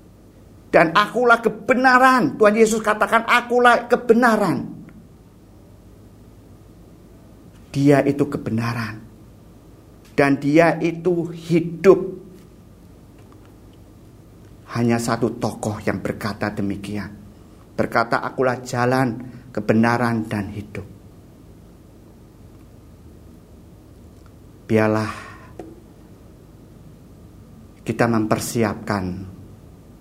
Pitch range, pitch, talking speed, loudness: 100-140 Hz, 110 Hz, 60 wpm, -19 LUFS